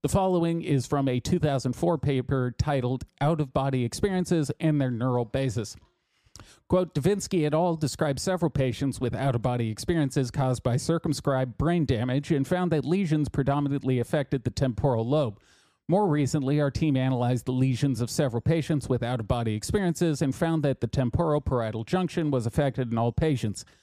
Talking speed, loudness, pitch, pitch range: 175 wpm, -27 LUFS, 140 Hz, 125-160 Hz